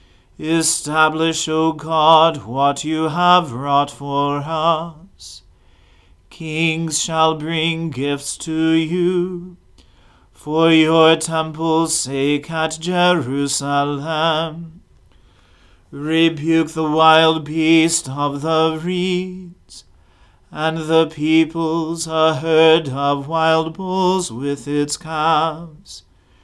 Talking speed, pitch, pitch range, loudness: 90 wpm, 160 Hz, 140-165 Hz, -17 LUFS